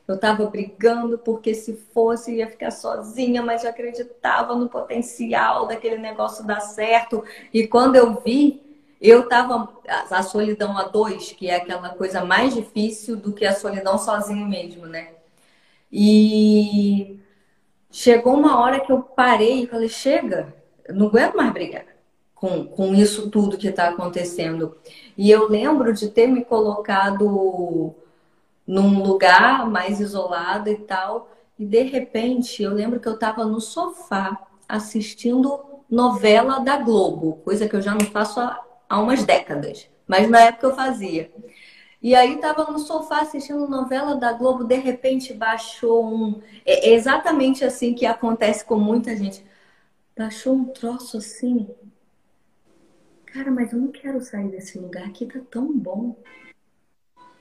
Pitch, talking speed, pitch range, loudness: 225 Hz, 150 wpm, 200-245 Hz, -20 LUFS